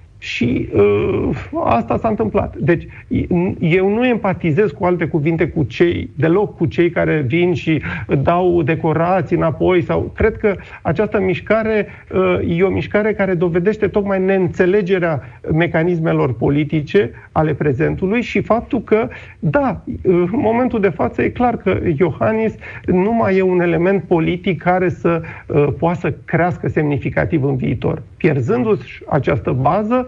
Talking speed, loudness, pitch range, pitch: 140 wpm, -17 LUFS, 160-195 Hz, 175 Hz